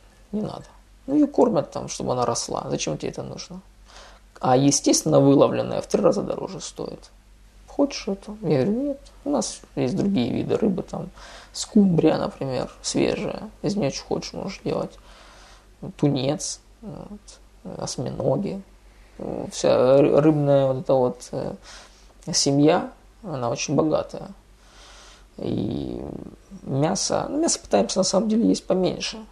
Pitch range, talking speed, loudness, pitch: 140-220 Hz, 130 wpm, -23 LUFS, 185 Hz